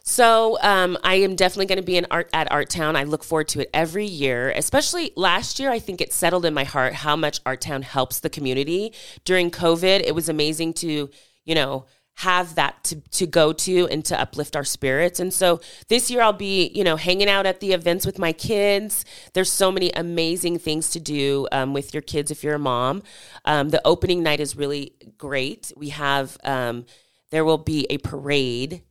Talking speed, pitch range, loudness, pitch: 210 wpm, 145-185 Hz, -21 LUFS, 160 Hz